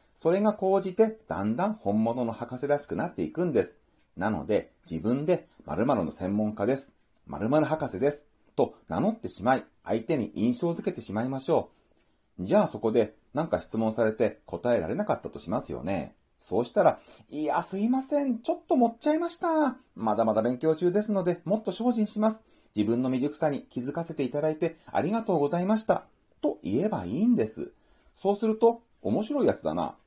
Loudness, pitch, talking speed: -28 LUFS, 170 Hz, 370 characters per minute